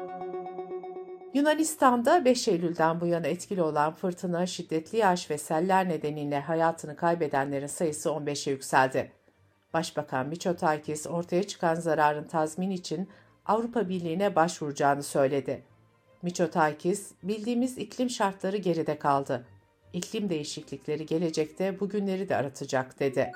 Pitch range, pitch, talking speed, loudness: 150-190 Hz, 165 Hz, 110 wpm, -29 LUFS